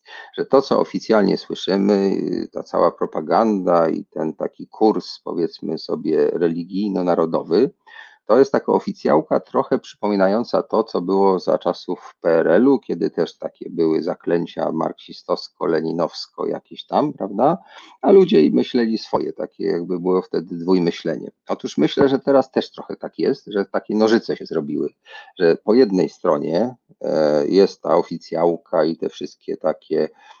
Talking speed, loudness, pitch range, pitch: 135 wpm, -20 LUFS, 85-115 Hz, 95 Hz